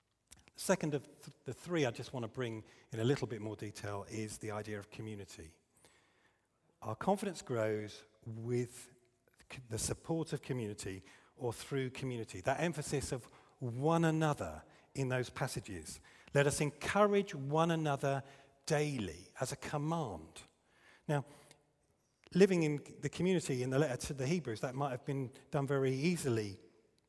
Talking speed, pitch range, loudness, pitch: 145 wpm, 110-145 Hz, -37 LUFS, 135 Hz